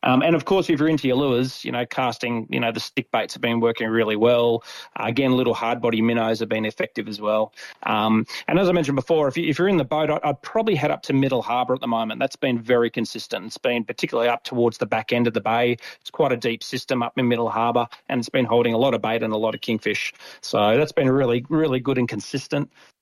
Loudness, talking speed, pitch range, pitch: -22 LUFS, 265 wpm, 115-135 Hz, 120 Hz